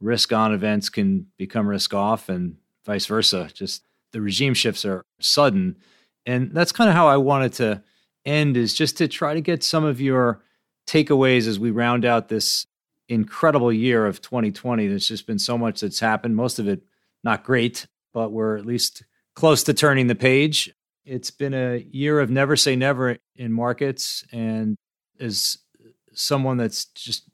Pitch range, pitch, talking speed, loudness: 110-140 Hz, 120 Hz, 175 wpm, -21 LUFS